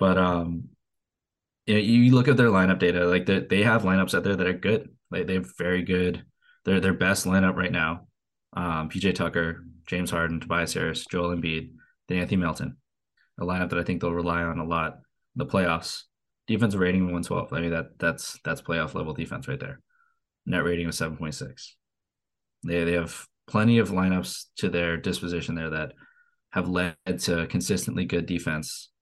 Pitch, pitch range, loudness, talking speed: 90 Hz, 85-95 Hz, -26 LUFS, 185 wpm